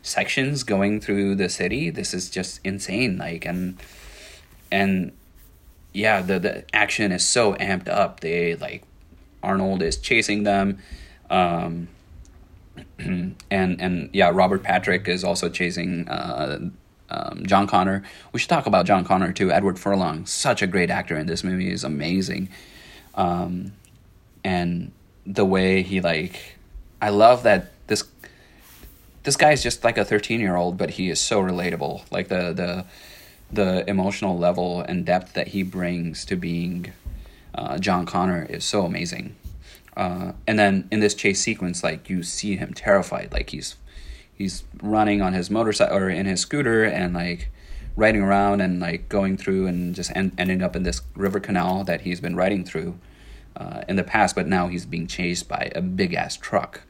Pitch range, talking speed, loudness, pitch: 85-100 Hz, 165 wpm, -23 LUFS, 90 Hz